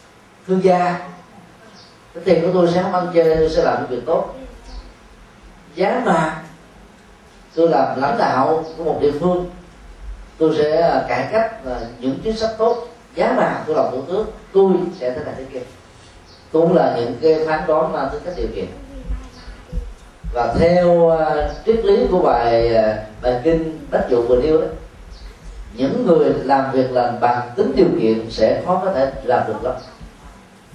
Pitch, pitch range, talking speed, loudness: 160 Hz, 120-180 Hz, 165 wpm, -18 LUFS